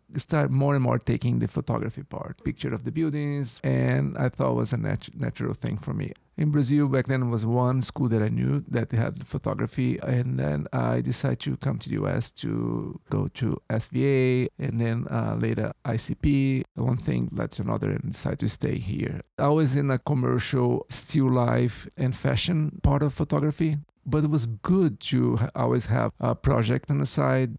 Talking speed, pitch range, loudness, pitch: 200 wpm, 115-145 Hz, -26 LUFS, 130 Hz